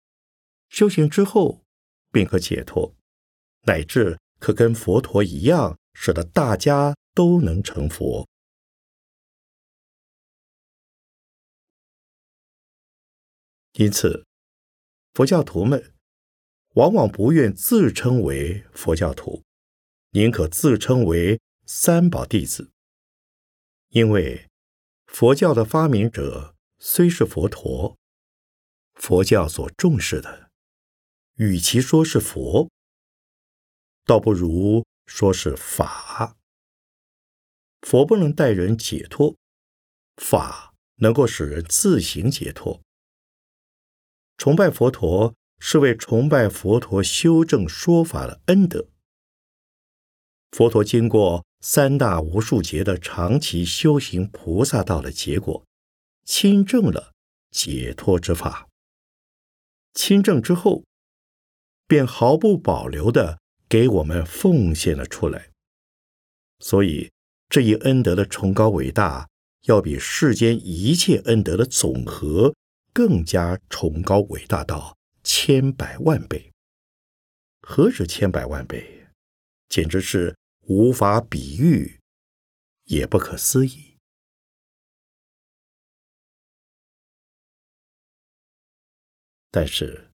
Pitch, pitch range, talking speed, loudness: 100 Hz, 80-130 Hz, 140 characters per minute, -20 LUFS